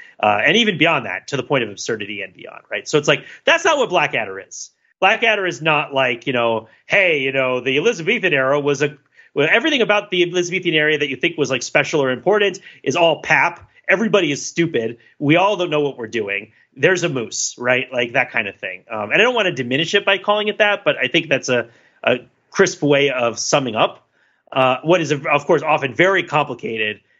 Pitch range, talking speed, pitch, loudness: 125-185 Hz, 225 wpm, 150 Hz, -17 LUFS